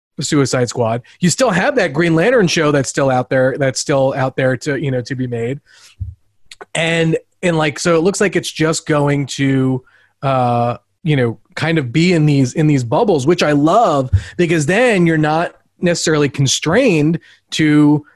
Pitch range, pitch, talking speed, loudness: 130-165 Hz, 150 Hz, 180 wpm, -15 LUFS